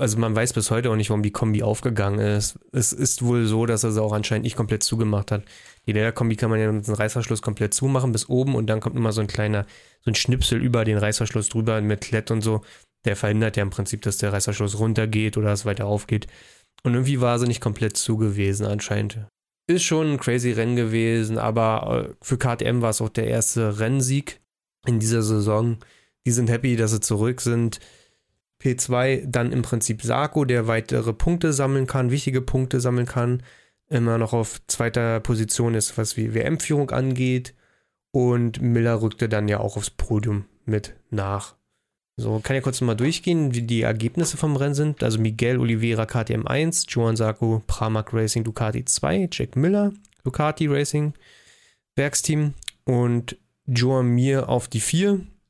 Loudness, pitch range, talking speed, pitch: -23 LUFS, 110-125 Hz, 180 wpm, 115 Hz